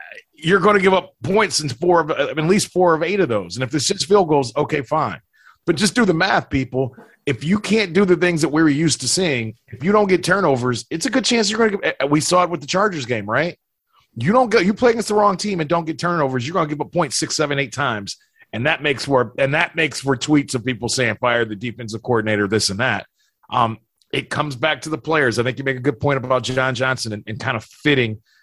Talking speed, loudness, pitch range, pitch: 265 wpm, -19 LUFS, 130-185 Hz, 150 Hz